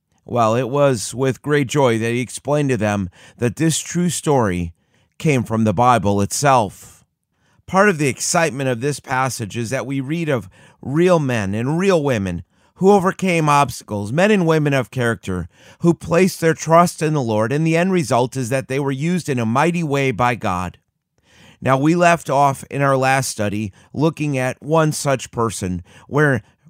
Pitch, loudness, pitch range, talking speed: 135 Hz, -18 LUFS, 115-155 Hz, 180 wpm